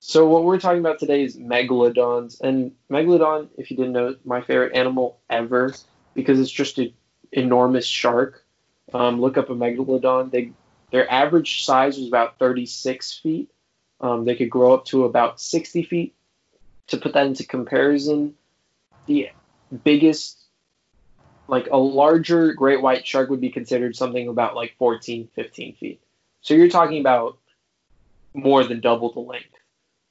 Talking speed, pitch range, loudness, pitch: 155 wpm, 125-145 Hz, -20 LUFS, 130 Hz